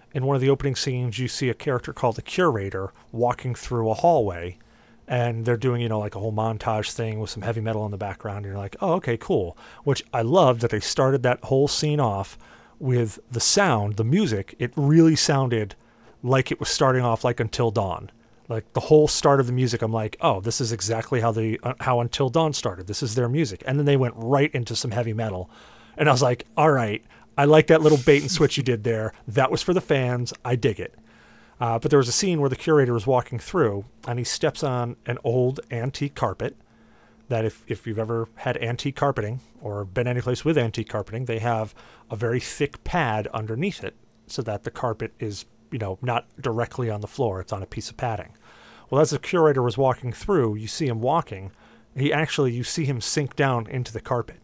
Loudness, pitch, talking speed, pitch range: -23 LUFS, 120 Hz, 225 wpm, 115-140 Hz